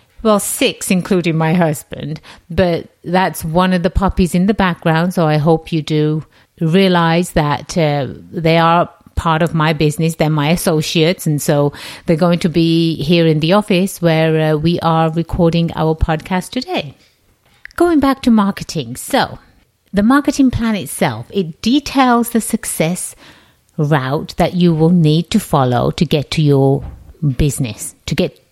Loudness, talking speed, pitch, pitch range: -15 LUFS, 160 wpm, 165 Hz, 155-185 Hz